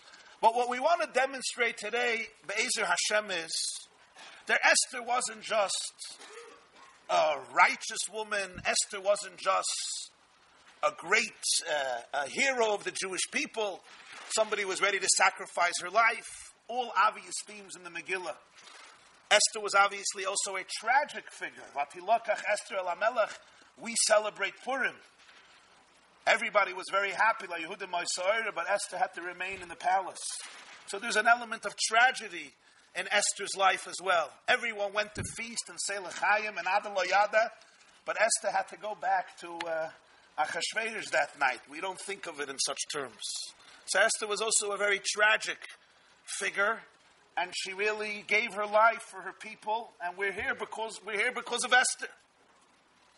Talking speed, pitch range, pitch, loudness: 145 wpm, 190-230 Hz, 205 Hz, -30 LUFS